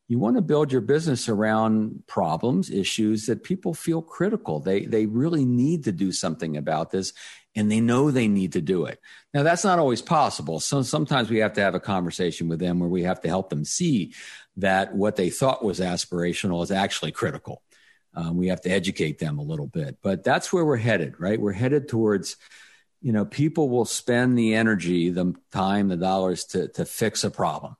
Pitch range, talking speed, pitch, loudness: 95-135 Hz, 205 wpm, 105 Hz, -24 LUFS